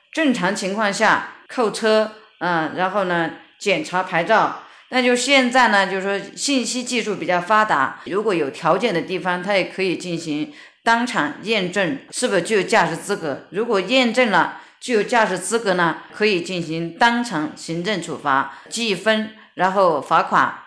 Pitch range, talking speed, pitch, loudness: 175-230 Hz, 245 characters per minute, 200 Hz, -19 LUFS